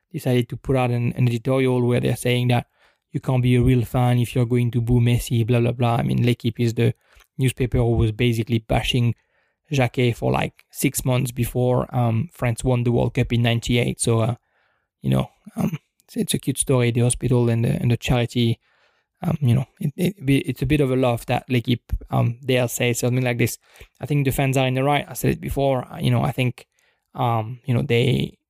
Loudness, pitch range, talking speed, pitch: -21 LUFS, 120-130 Hz, 225 wpm, 125 Hz